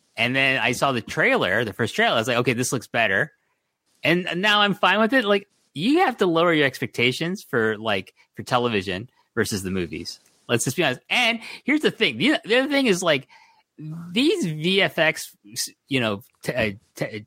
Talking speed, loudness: 190 wpm, -22 LUFS